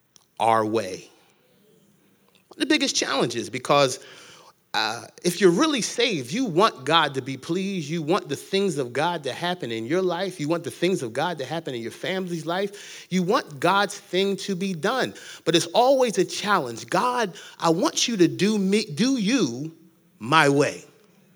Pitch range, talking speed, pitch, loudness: 165-200 Hz, 185 wpm, 180 Hz, -23 LUFS